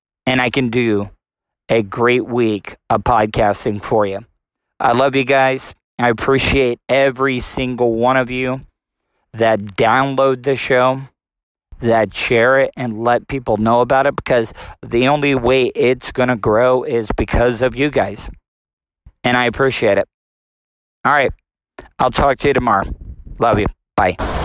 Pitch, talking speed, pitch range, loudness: 125 Hz, 150 wpm, 110-130 Hz, -16 LUFS